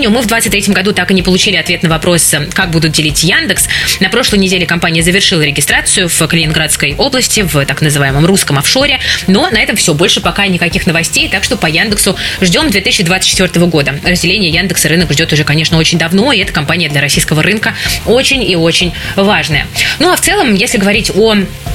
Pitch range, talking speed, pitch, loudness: 165-200 Hz, 190 wpm, 180 Hz, -9 LUFS